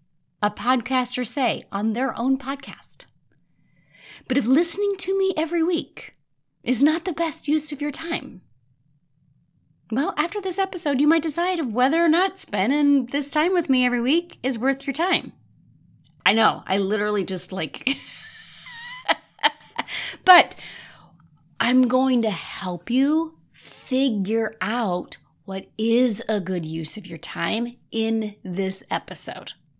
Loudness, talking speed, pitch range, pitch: -22 LUFS, 140 wpm, 195-310 Hz, 255 Hz